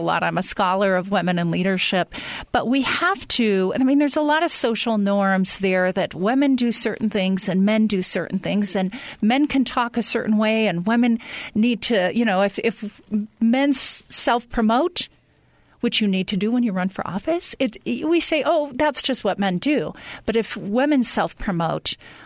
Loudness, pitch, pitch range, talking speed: -21 LUFS, 220 Hz, 195-260 Hz, 190 wpm